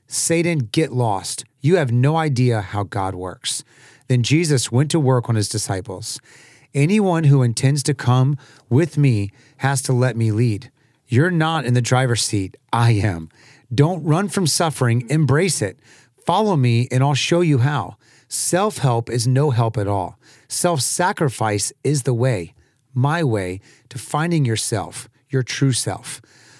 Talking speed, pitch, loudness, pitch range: 160 wpm, 130 Hz, -19 LUFS, 115-145 Hz